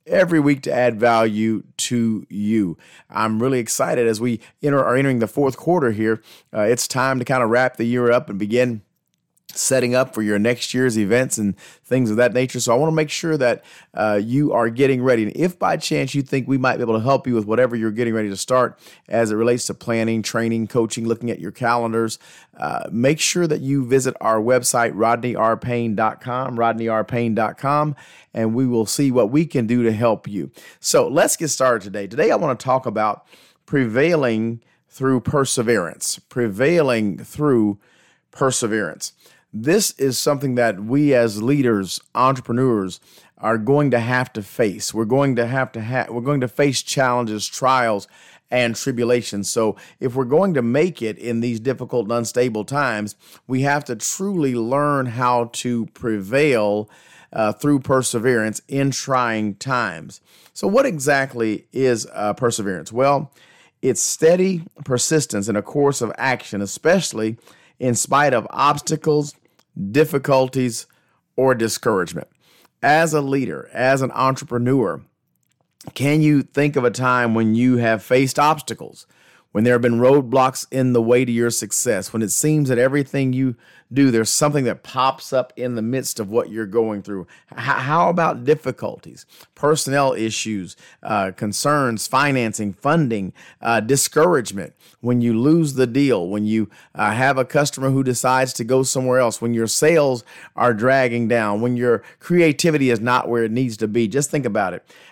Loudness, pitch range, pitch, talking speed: -19 LUFS, 115-135 Hz, 125 Hz, 170 wpm